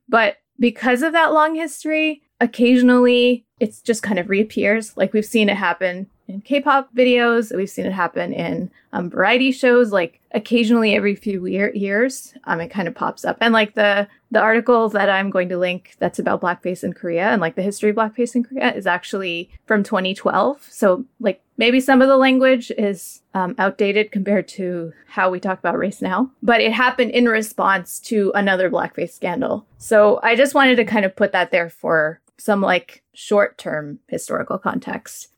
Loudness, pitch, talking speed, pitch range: -18 LUFS, 215 Hz, 185 wpm, 190-245 Hz